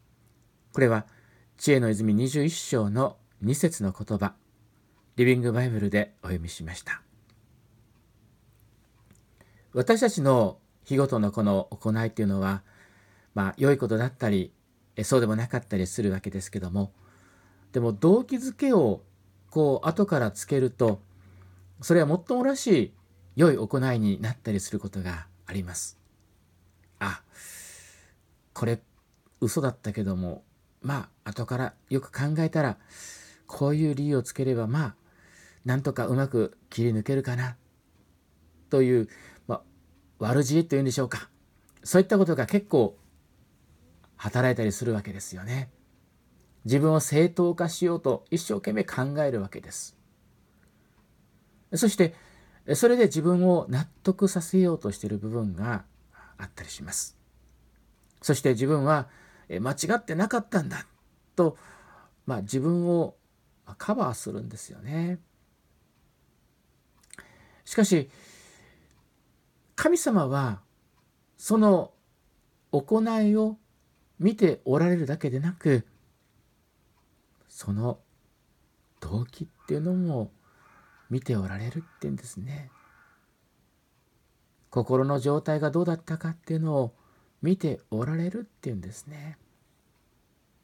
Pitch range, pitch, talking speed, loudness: 100-155 Hz, 120 Hz, 240 characters per minute, -27 LUFS